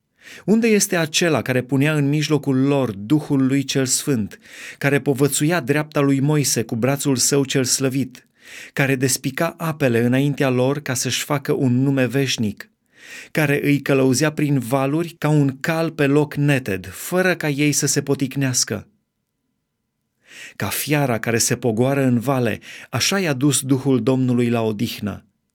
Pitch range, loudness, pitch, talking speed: 130-145 Hz, -19 LUFS, 140 Hz, 150 wpm